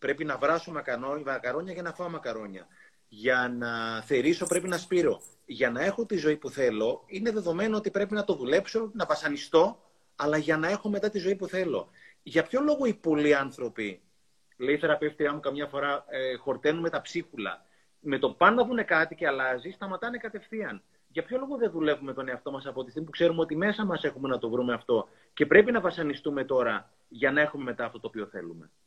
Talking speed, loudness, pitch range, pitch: 205 wpm, -28 LUFS, 135-195 Hz, 155 Hz